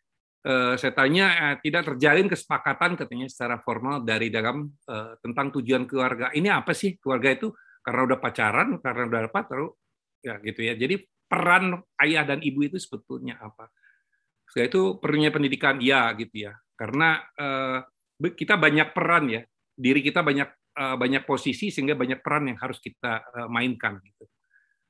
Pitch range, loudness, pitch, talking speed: 125-165 Hz, -24 LUFS, 135 Hz, 160 wpm